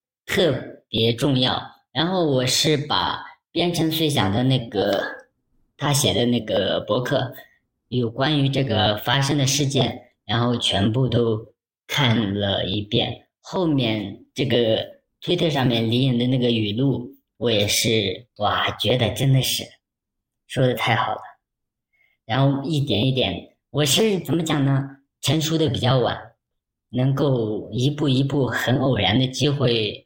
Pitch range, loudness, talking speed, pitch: 115-140 Hz, -21 LUFS, 200 characters per minute, 125 Hz